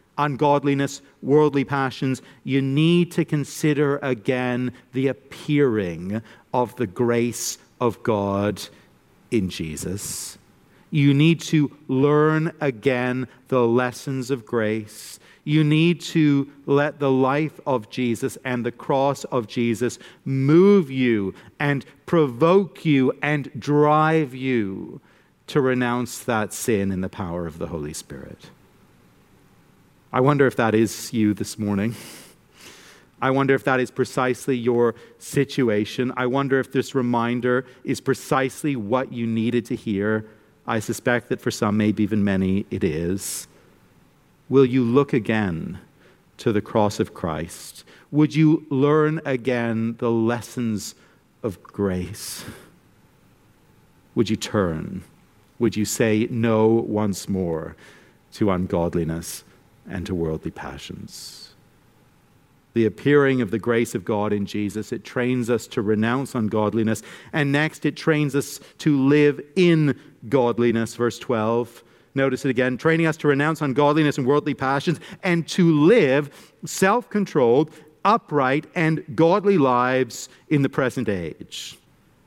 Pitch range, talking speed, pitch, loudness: 110-145 Hz, 130 wpm, 130 Hz, -22 LUFS